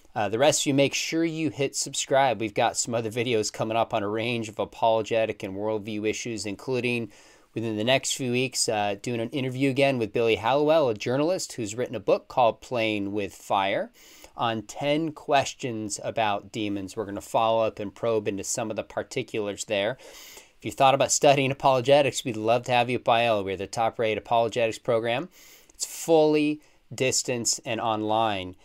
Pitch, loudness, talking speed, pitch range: 115 Hz, -25 LUFS, 190 wpm, 110-135 Hz